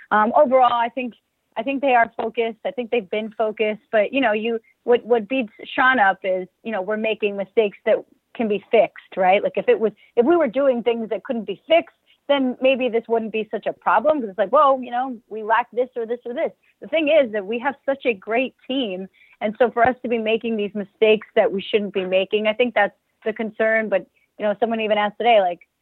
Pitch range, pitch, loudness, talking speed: 215-255 Hz, 230 Hz, -21 LUFS, 245 wpm